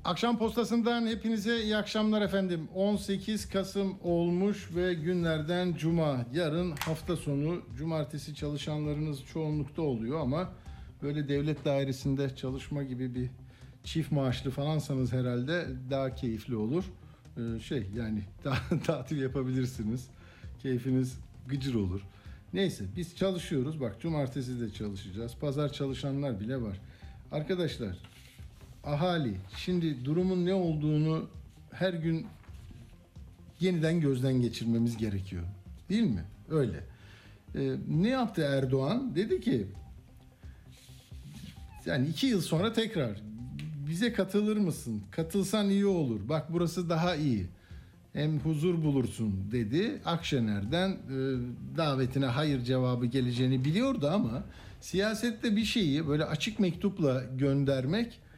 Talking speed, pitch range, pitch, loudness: 110 wpm, 125-175 Hz, 145 Hz, -32 LUFS